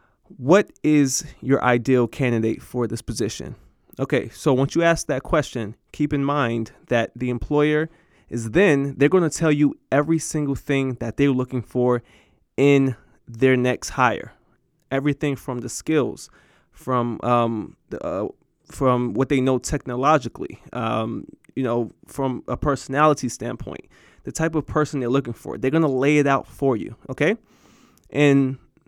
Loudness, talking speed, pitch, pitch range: -22 LUFS, 160 wpm, 135 Hz, 125-150 Hz